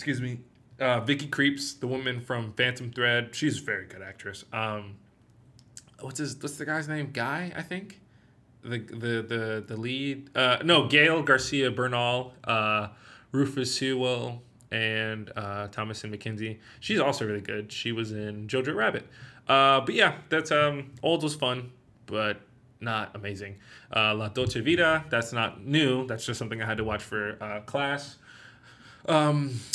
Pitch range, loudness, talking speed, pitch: 110-140 Hz, -27 LUFS, 160 wpm, 125 Hz